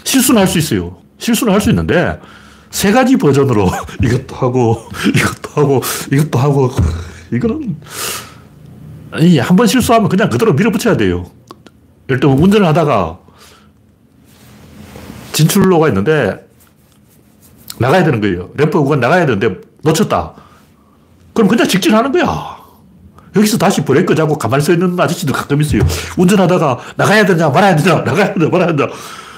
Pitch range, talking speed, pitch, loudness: 125-195 Hz, 325 characters per minute, 155 Hz, -12 LUFS